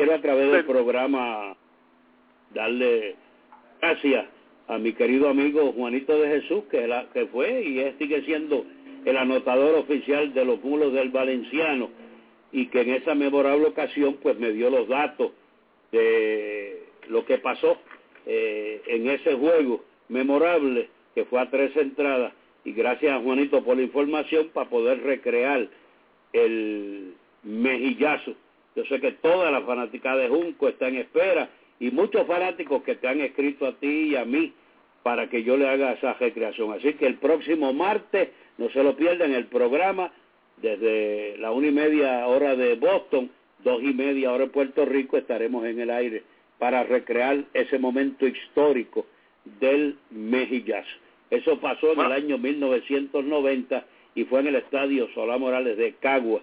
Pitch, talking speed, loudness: 145 Hz, 155 wpm, -24 LUFS